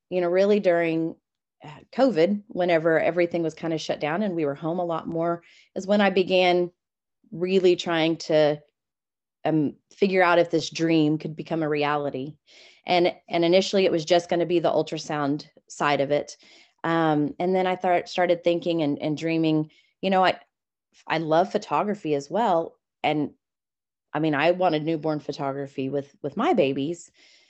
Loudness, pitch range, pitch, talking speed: -24 LUFS, 155-180 Hz, 165 Hz, 170 wpm